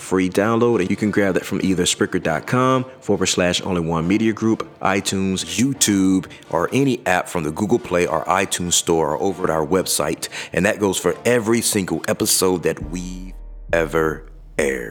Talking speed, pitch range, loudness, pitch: 175 wpm, 90-105 Hz, -19 LUFS, 95 Hz